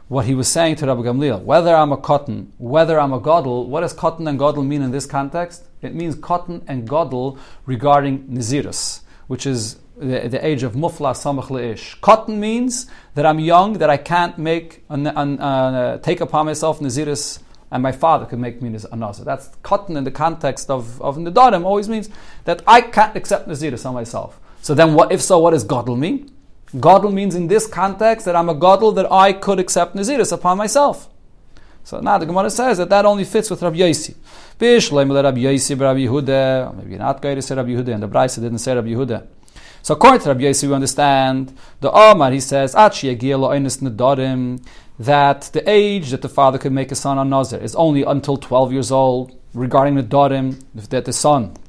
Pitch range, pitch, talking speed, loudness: 130-175 Hz, 140 Hz, 190 wpm, -16 LUFS